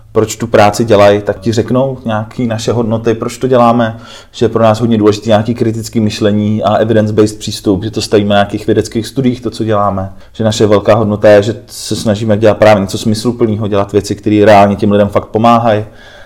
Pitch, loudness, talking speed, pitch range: 110 Hz, -11 LUFS, 205 wpm, 105-115 Hz